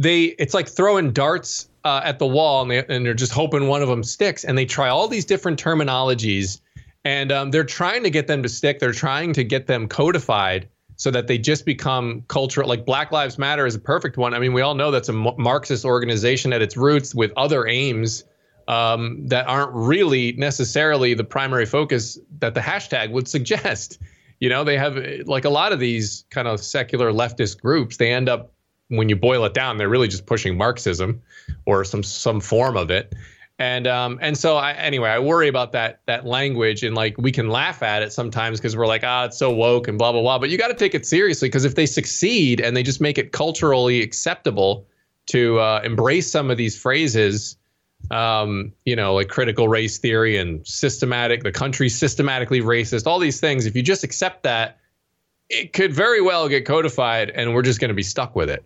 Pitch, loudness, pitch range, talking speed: 125 Hz, -20 LUFS, 115-145 Hz, 215 wpm